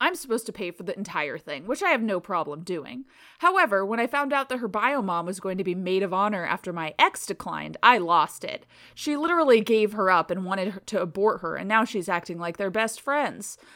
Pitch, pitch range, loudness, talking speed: 205 Hz, 185-250 Hz, -25 LUFS, 240 wpm